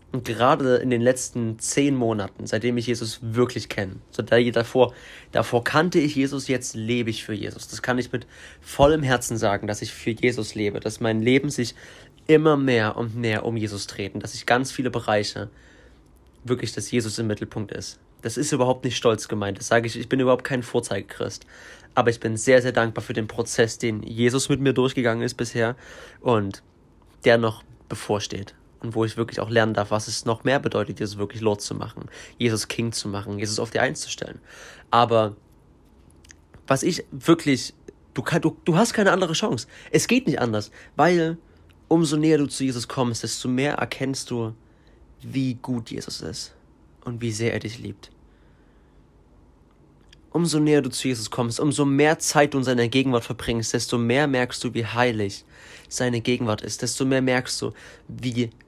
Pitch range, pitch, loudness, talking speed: 110-130 Hz, 120 Hz, -23 LUFS, 185 wpm